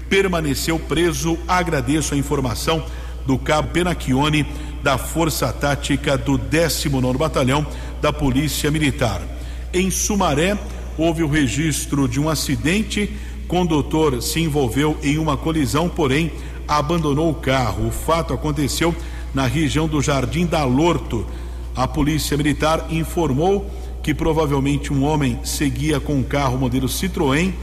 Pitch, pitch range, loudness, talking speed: 150 Hz, 135-160 Hz, -20 LUFS, 130 wpm